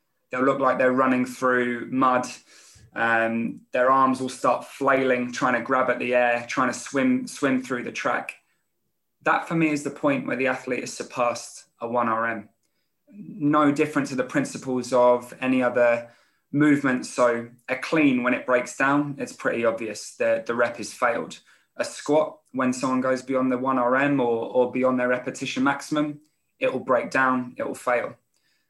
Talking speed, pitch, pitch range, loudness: 175 wpm, 130 Hz, 125-135 Hz, -24 LUFS